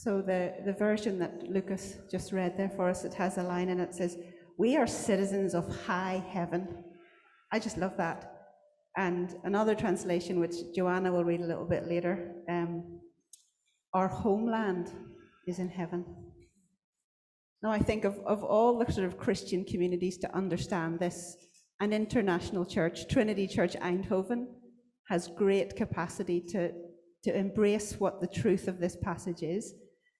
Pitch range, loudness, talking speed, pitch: 175-200 Hz, -32 LUFS, 155 wpm, 185 Hz